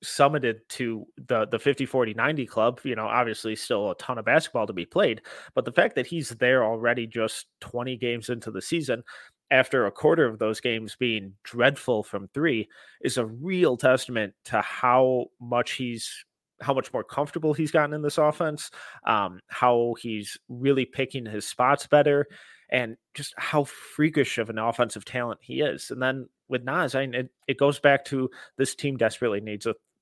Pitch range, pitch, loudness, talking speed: 115-140 Hz, 125 Hz, -26 LUFS, 185 wpm